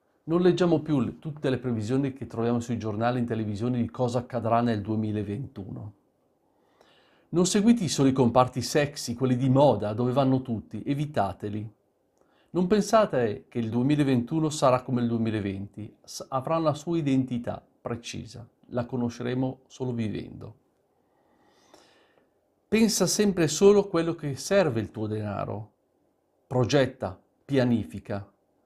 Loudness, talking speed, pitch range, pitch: -26 LUFS, 130 wpm, 115-145 Hz, 125 Hz